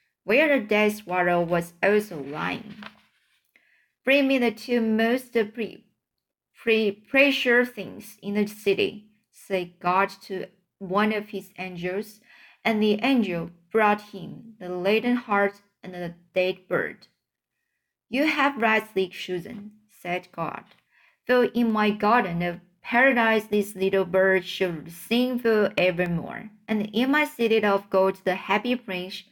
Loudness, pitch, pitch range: -24 LUFS, 210 Hz, 185-230 Hz